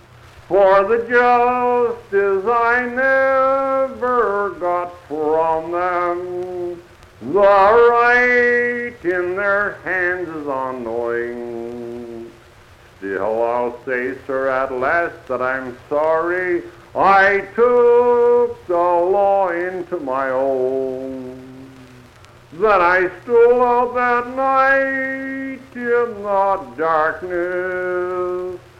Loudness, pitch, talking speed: -17 LUFS, 180 Hz, 85 wpm